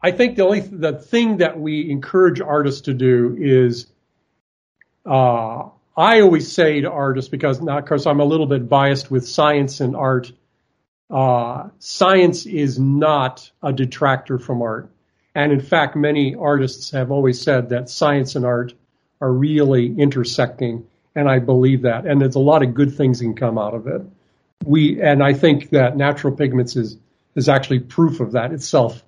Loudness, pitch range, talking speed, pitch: -17 LUFS, 125-150 Hz, 175 wpm, 140 Hz